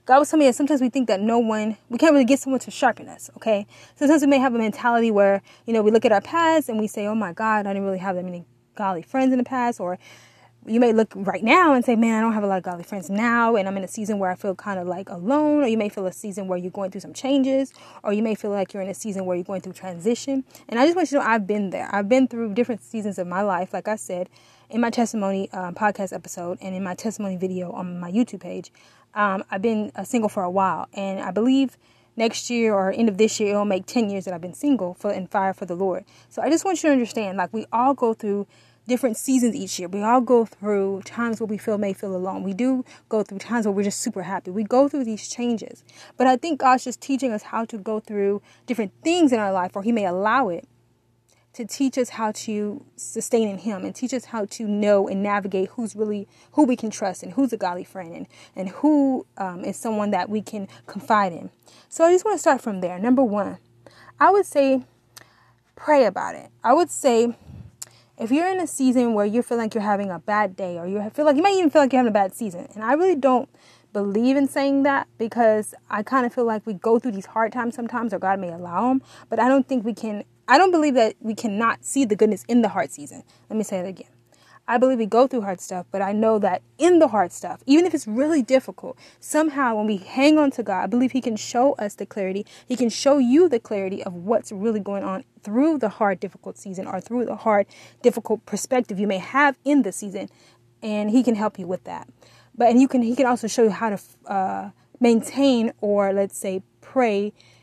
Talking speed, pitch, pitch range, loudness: 255 wpm, 220 Hz, 195-250 Hz, -22 LUFS